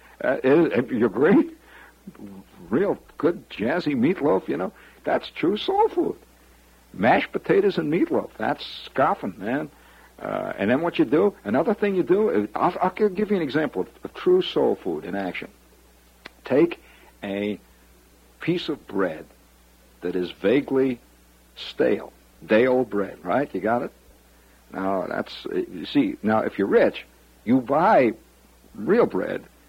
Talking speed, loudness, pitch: 140 wpm, -23 LUFS, 110 Hz